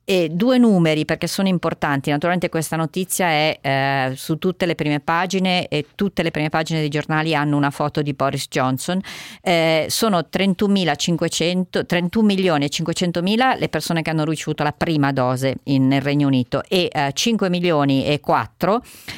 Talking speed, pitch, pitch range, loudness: 160 wpm, 160 Hz, 145-180 Hz, -19 LUFS